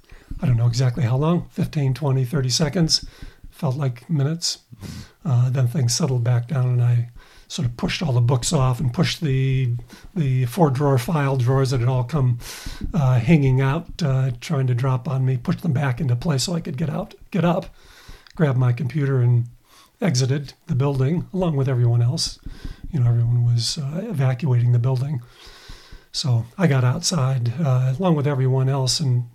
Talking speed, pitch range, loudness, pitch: 180 wpm, 125-155 Hz, -21 LUFS, 135 Hz